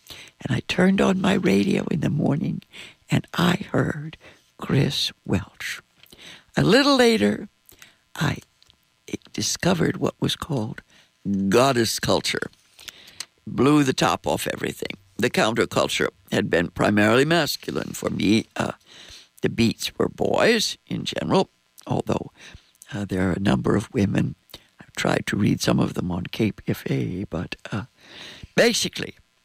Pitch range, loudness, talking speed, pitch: 100-160 Hz, -23 LUFS, 130 wpm, 115 Hz